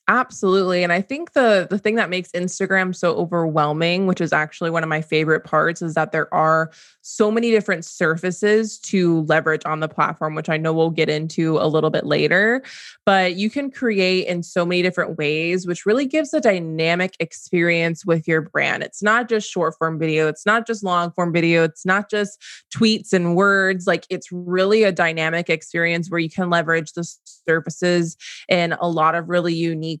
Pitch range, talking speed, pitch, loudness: 160-195 Hz, 195 wpm, 175 Hz, -19 LUFS